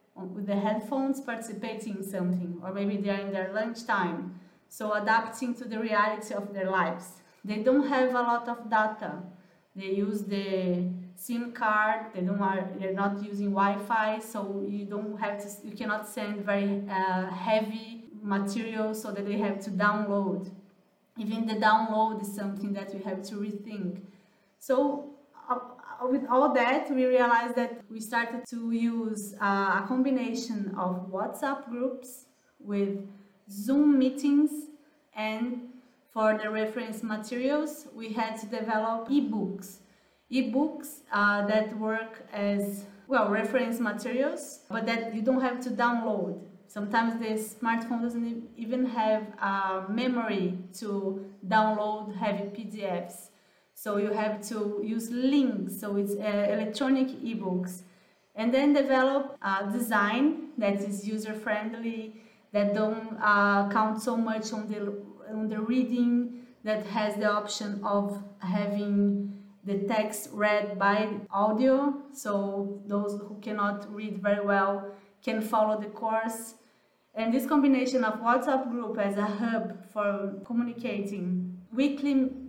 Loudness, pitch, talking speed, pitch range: -29 LUFS, 215 Hz, 140 wpm, 200-235 Hz